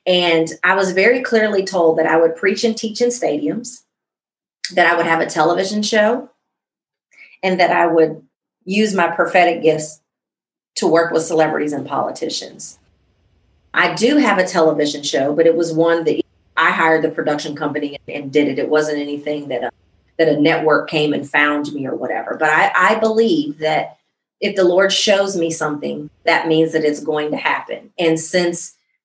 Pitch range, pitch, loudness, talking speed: 150-190 Hz, 165 Hz, -16 LUFS, 180 wpm